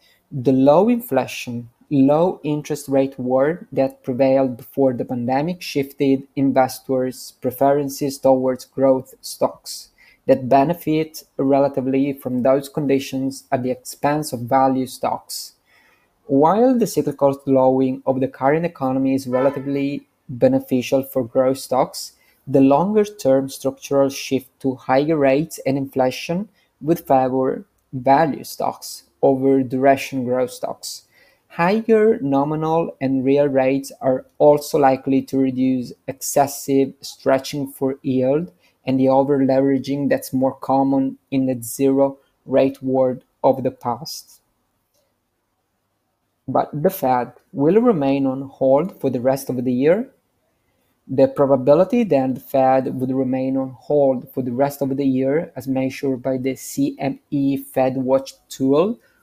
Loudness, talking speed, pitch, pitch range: -19 LUFS, 125 wpm, 135 Hz, 130-140 Hz